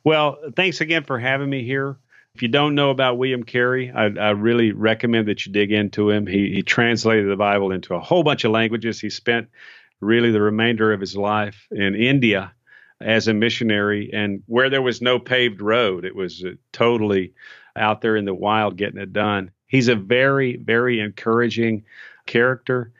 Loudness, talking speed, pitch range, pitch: -20 LUFS, 185 wpm, 105-125 Hz, 115 Hz